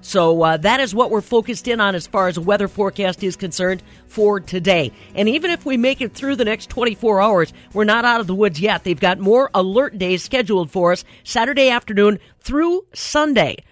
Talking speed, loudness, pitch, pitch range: 210 wpm, -18 LUFS, 210 Hz, 185-245 Hz